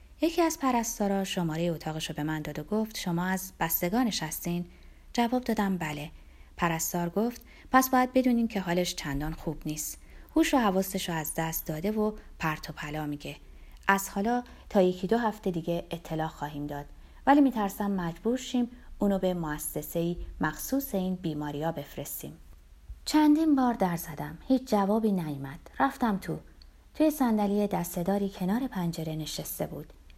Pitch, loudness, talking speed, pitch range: 185 Hz, -29 LUFS, 155 wpm, 155-220 Hz